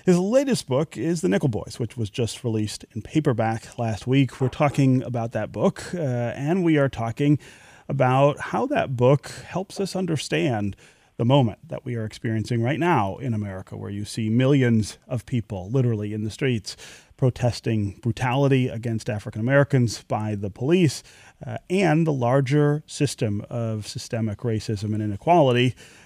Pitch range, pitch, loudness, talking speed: 110-145 Hz, 125 Hz, -23 LUFS, 160 wpm